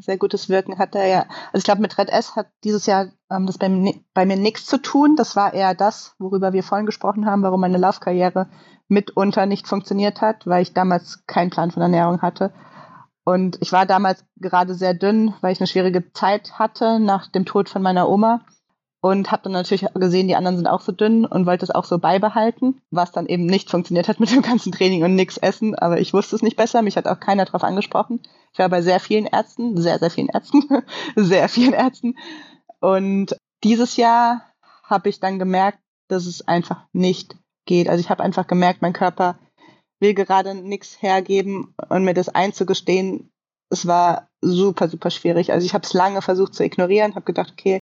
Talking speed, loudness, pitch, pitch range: 205 wpm, -19 LUFS, 190 Hz, 185-210 Hz